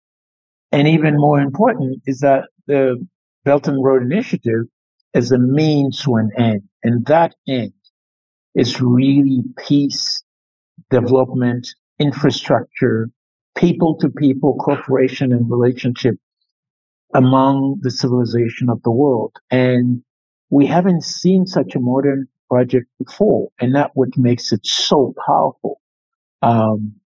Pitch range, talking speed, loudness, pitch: 120-145 Hz, 115 wpm, -16 LUFS, 130 Hz